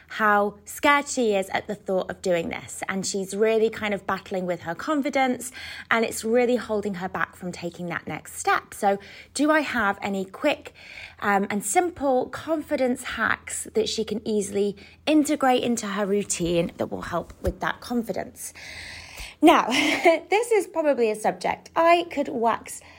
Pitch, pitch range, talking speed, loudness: 220 Hz, 200-285 Hz, 165 wpm, -24 LUFS